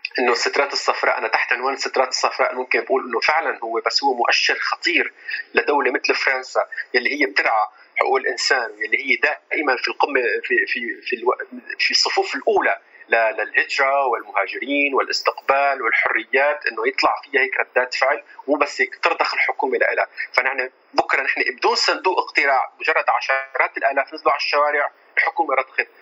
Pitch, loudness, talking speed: 390 Hz, -19 LUFS, 155 wpm